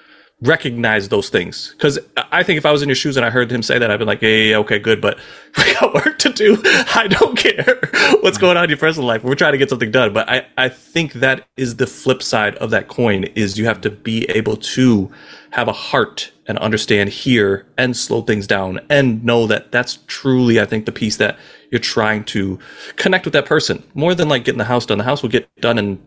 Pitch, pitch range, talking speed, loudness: 125 Hz, 110-135 Hz, 245 wpm, -15 LUFS